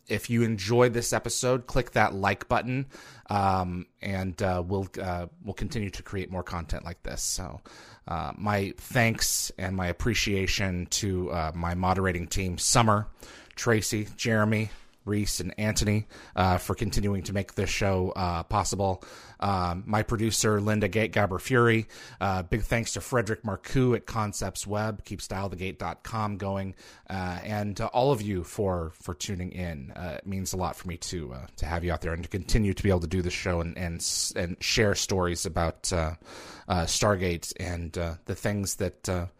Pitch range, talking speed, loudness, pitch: 90-110 Hz, 180 wpm, -28 LUFS, 95 Hz